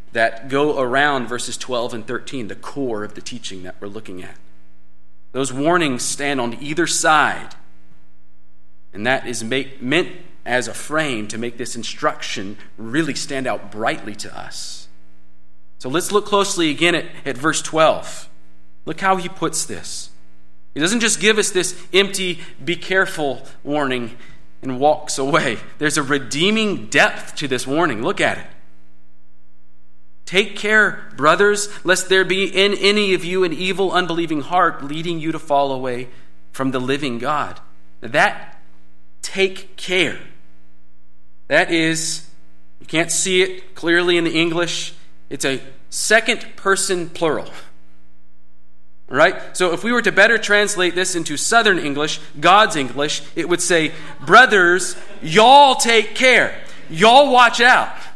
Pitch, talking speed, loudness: 145 Hz, 150 wpm, -17 LUFS